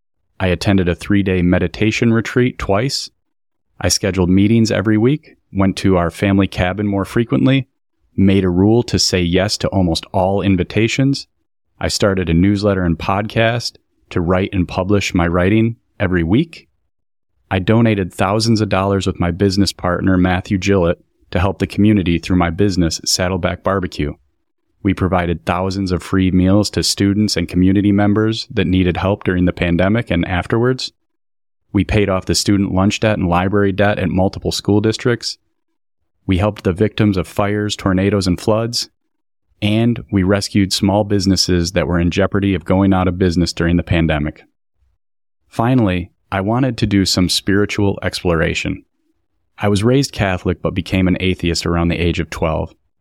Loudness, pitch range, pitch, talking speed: -16 LUFS, 90-105 Hz, 95 Hz, 165 wpm